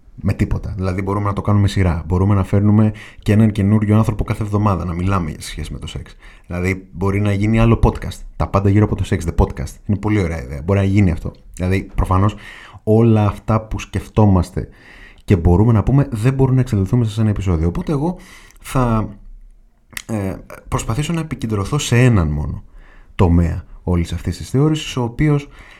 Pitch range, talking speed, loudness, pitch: 95-110 Hz, 185 wpm, -17 LUFS, 105 Hz